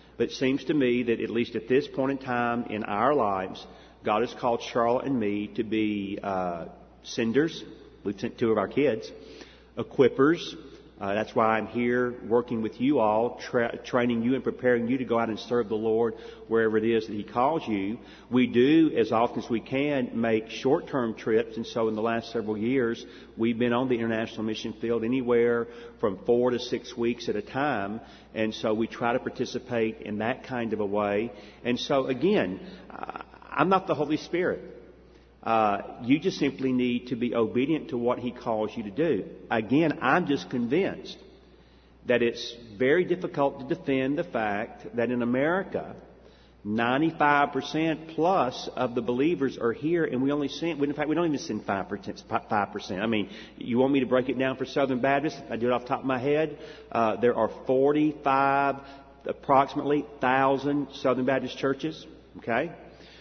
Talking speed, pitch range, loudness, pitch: 185 wpm, 115-135 Hz, -27 LUFS, 120 Hz